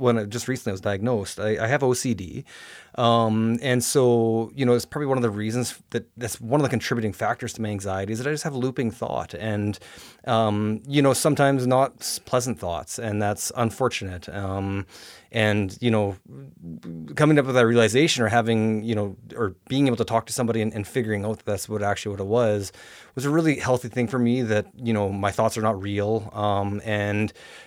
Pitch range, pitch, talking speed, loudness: 105-125 Hz, 115 Hz, 215 wpm, -24 LUFS